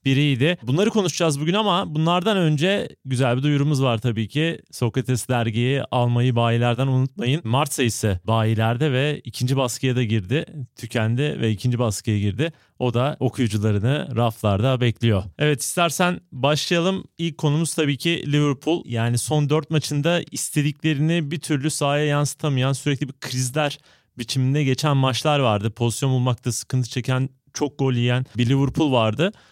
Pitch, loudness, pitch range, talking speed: 135 Hz, -22 LUFS, 120-150 Hz, 140 wpm